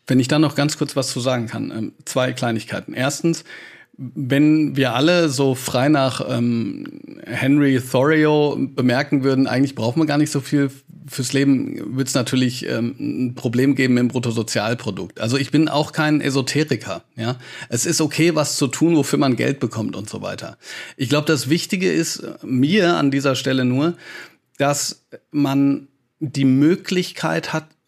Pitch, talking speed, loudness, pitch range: 140 Hz, 165 wpm, -19 LUFS, 130-150 Hz